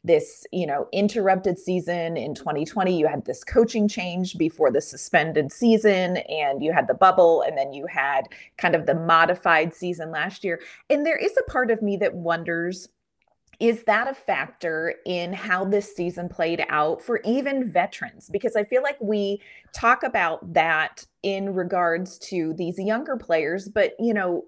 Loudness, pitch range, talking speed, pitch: -23 LUFS, 170-220 Hz, 175 wpm, 185 Hz